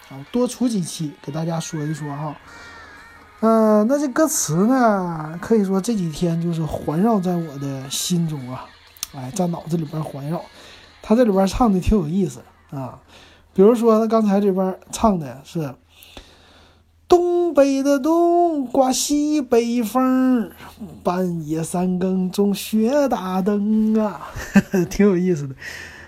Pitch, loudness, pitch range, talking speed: 190 Hz, -20 LUFS, 160-230 Hz, 200 characters per minute